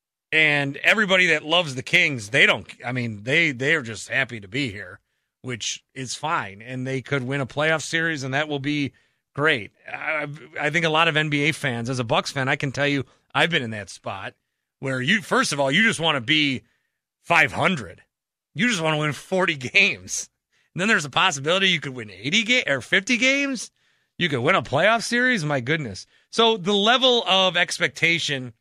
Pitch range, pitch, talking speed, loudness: 135-185 Hz, 150 Hz, 205 wpm, -21 LUFS